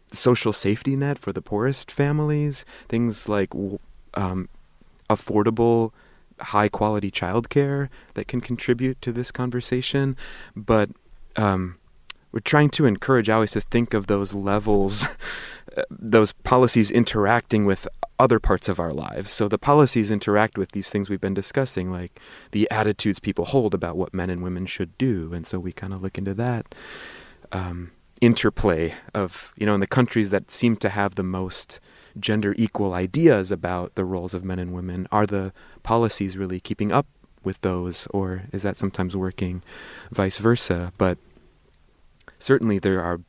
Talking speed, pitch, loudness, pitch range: 160 wpm, 105 Hz, -23 LUFS, 95-115 Hz